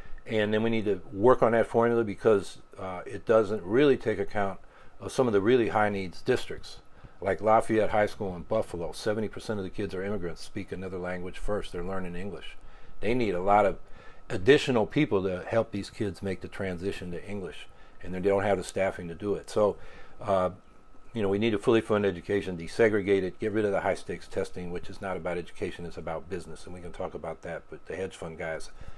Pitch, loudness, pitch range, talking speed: 100 Hz, -29 LUFS, 90-105 Hz, 220 wpm